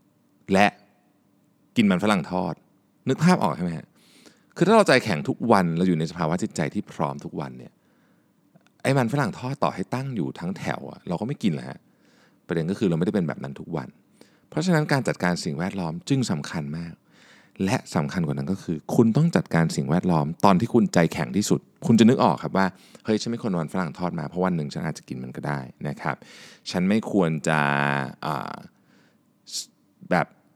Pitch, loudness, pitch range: 90 Hz, -24 LUFS, 75-125 Hz